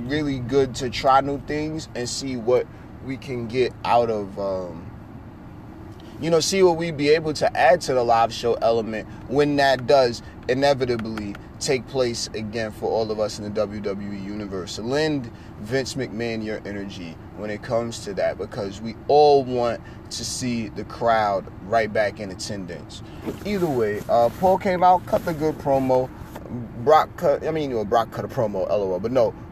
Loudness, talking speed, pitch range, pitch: -22 LUFS, 180 wpm, 105-135 Hz, 115 Hz